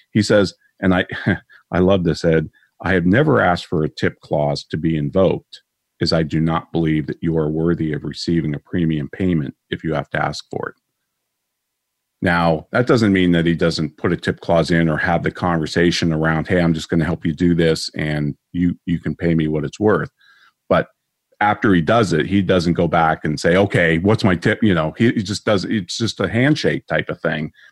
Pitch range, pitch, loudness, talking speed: 80-95 Hz, 85 Hz, -18 LUFS, 220 wpm